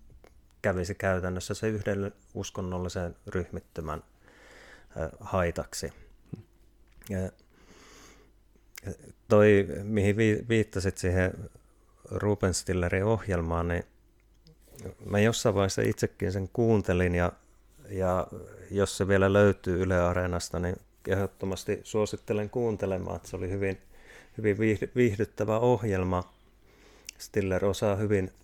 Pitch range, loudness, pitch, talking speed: 90-105 Hz, -29 LUFS, 100 Hz, 90 wpm